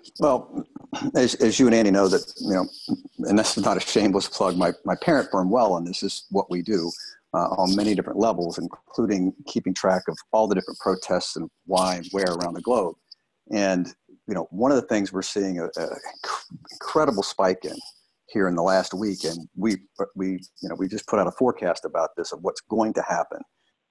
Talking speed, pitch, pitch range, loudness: 215 wpm, 95 Hz, 90-105 Hz, -24 LUFS